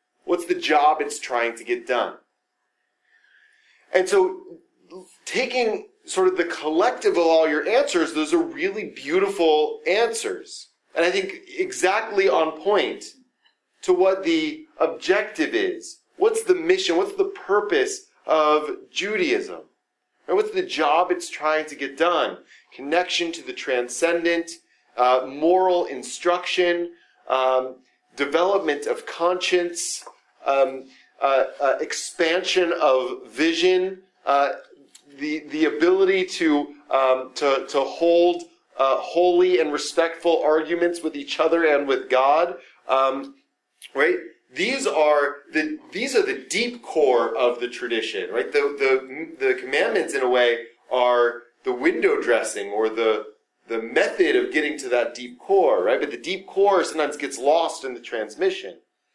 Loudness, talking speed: -22 LUFS, 135 wpm